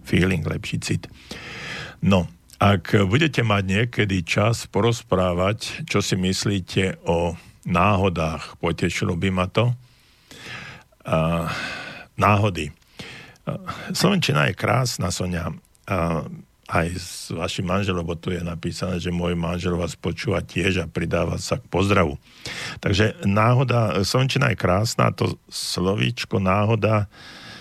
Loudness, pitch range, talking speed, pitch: -22 LUFS, 85-110 Hz, 115 wpm, 95 Hz